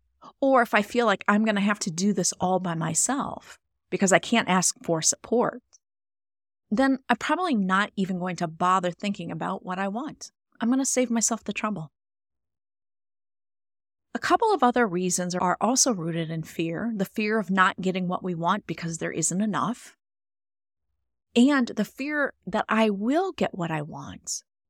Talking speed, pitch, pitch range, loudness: 175 wpm, 190 Hz, 165-225 Hz, -25 LUFS